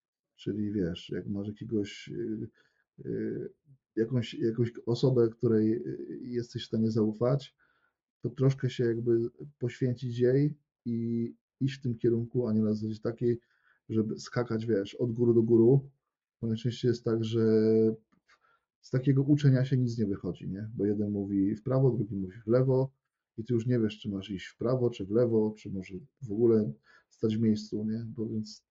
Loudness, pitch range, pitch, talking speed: -30 LUFS, 110-125 Hz, 115 Hz, 170 wpm